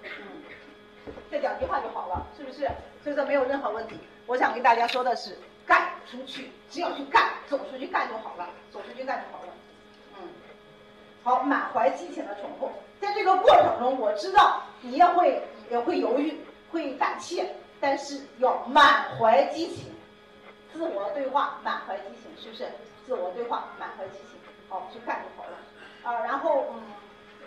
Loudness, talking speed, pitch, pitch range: -26 LUFS, 245 characters per minute, 280 Hz, 250-330 Hz